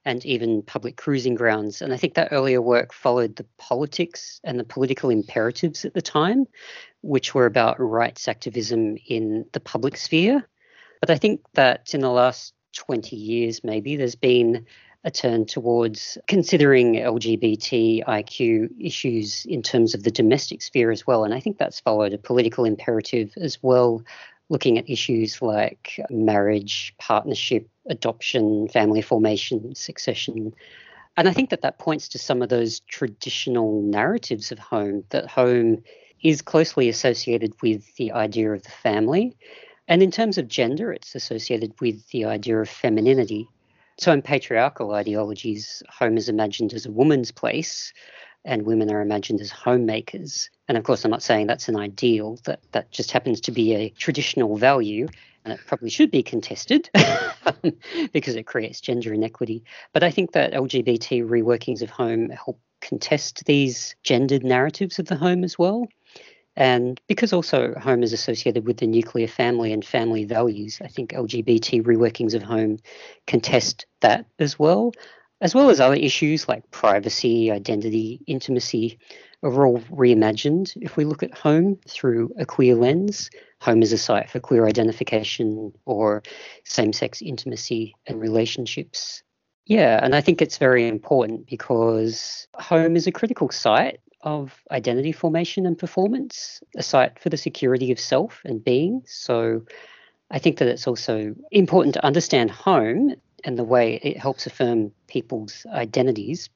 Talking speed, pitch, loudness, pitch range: 155 wpm, 120 Hz, -22 LUFS, 110-155 Hz